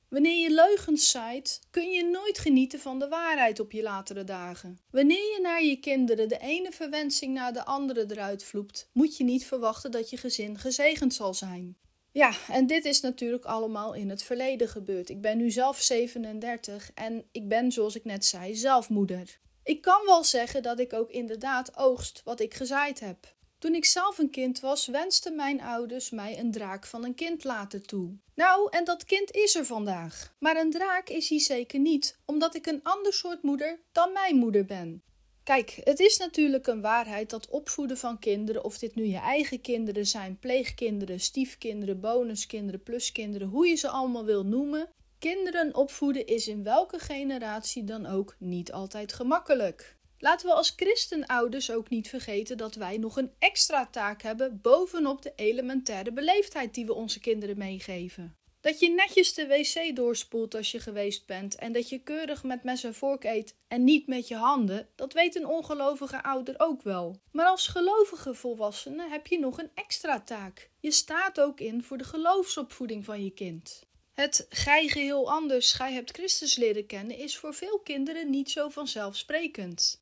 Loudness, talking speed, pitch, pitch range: -28 LUFS, 180 wpm, 255 Hz, 220-300 Hz